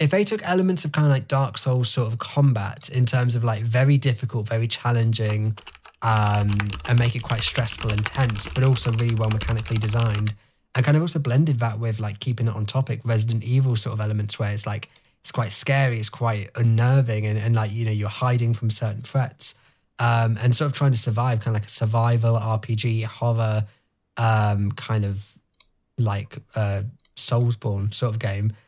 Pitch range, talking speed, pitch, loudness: 110-125 Hz, 195 wpm, 115 Hz, -22 LUFS